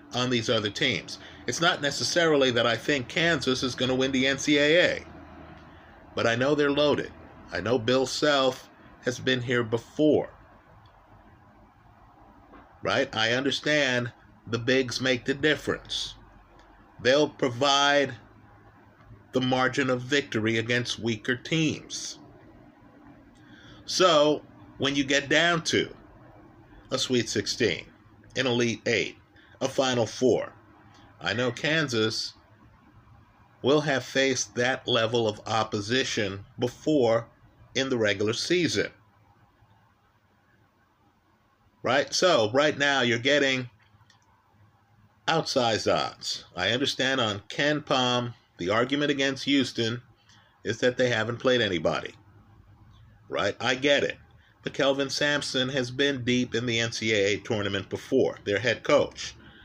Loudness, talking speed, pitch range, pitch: -26 LUFS, 120 wpm, 105-135 Hz, 120 Hz